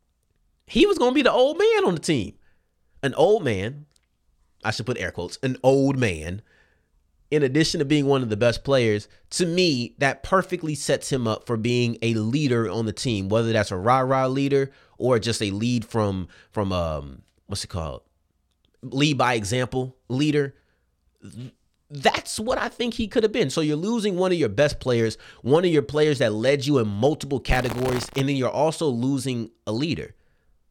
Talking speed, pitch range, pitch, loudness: 190 wpm, 105-145 Hz, 125 Hz, -23 LUFS